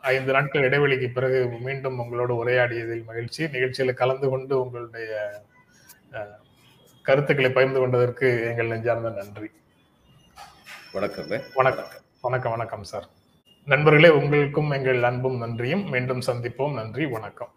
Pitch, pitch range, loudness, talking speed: 125 Hz, 115-135 Hz, -23 LUFS, 110 wpm